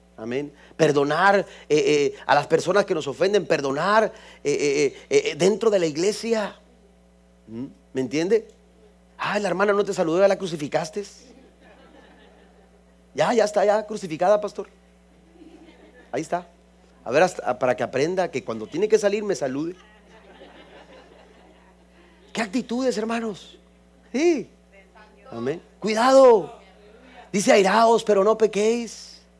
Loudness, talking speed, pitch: -22 LUFS, 120 wpm, 200 Hz